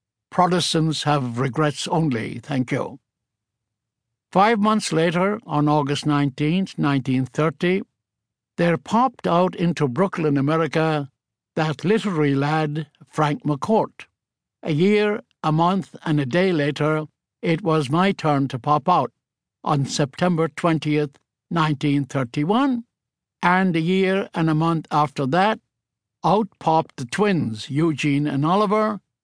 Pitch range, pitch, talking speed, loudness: 140-180 Hz, 155 Hz, 125 wpm, -21 LUFS